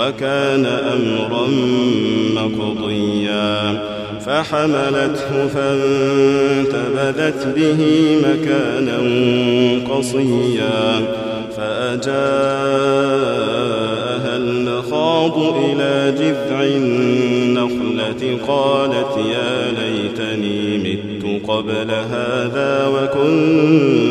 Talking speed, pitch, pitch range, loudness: 50 wpm, 125 Hz, 110-140 Hz, -17 LUFS